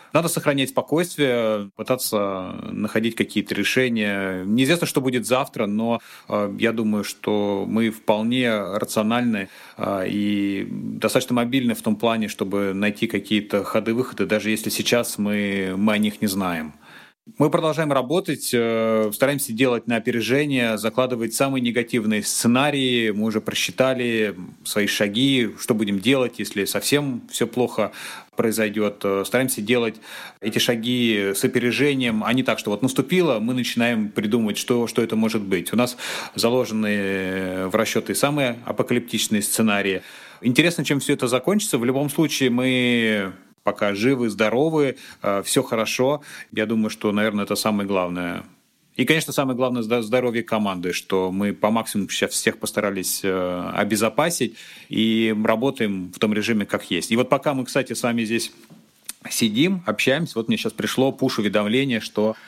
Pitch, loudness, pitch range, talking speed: 115 Hz, -22 LUFS, 105-130 Hz, 140 wpm